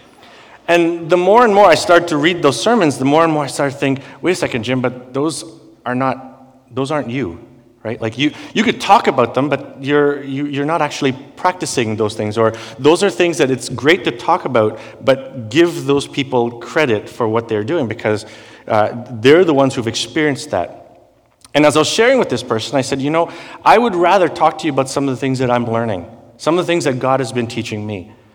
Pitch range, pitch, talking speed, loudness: 120-155 Hz, 135 Hz, 235 wpm, -15 LUFS